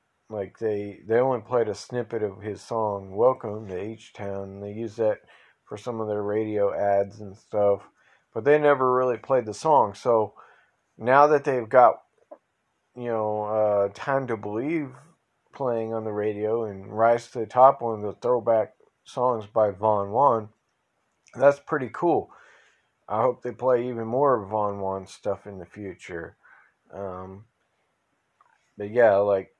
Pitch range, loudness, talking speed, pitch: 100-120 Hz, -24 LUFS, 160 wpm, 110 Hz